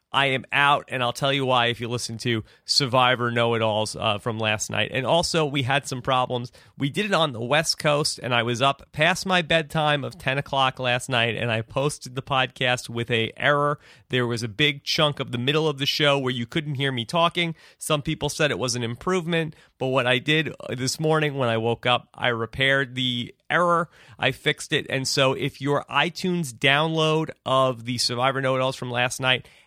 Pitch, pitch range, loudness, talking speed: 135 Hz, 120-150 Hz, -23 LUFS, 220 wpm